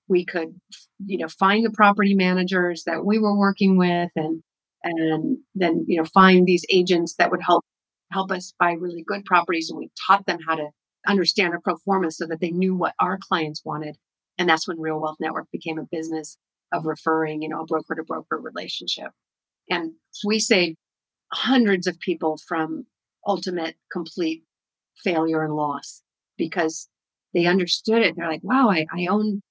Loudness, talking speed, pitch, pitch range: -22 LUFS, 175 wpm, 175 Hz, 160-195 Hz